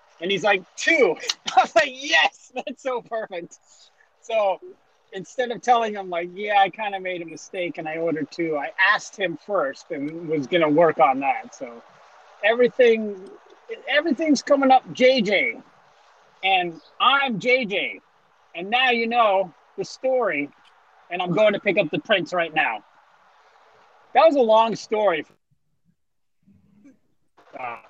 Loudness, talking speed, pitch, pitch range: -21 LUFS, 150 wpm, 210 Hz, 175-260 Hz